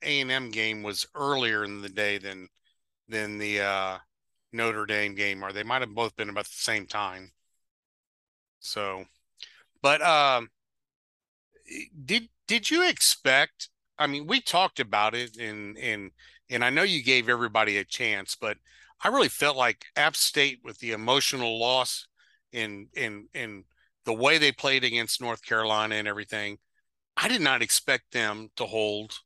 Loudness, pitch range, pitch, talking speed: -26 LUFS, 105-130 Hz, 110 Hz, 165 wpm